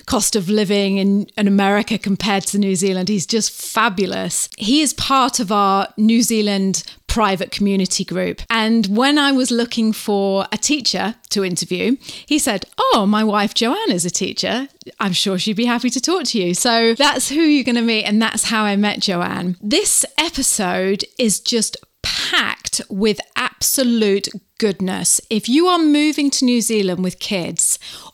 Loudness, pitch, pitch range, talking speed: -17 LUFS, 215 Hz, 195-245 Hz, 170 wpm